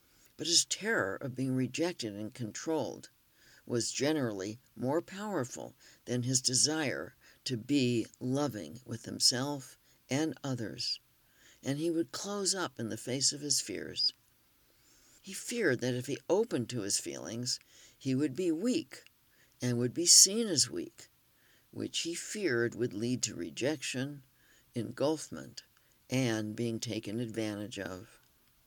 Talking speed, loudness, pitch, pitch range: 135 wpm, -32 LUFS, 130 Hz, 115-155 Hz